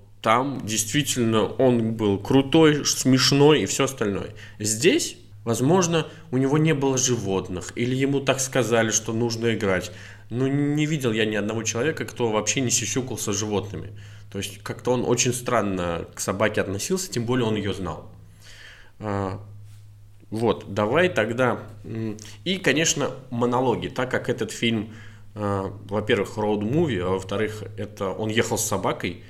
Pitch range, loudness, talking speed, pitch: 105-130 Hz, -23 LUFS, 140 wpm, 110 Hz